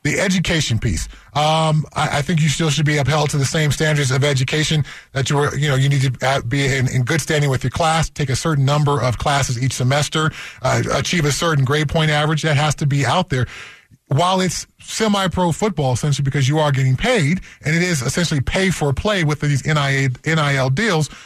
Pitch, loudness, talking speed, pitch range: 145 Hz, -18 LUFS, 215 wpm, 135-160 Hz